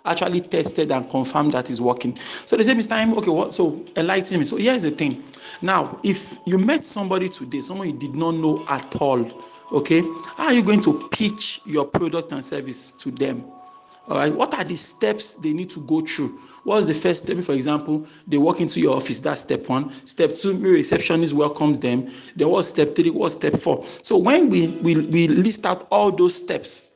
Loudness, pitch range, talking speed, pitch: -20 LUFS, 150-215 Hz, 210 wpm, 170 Hz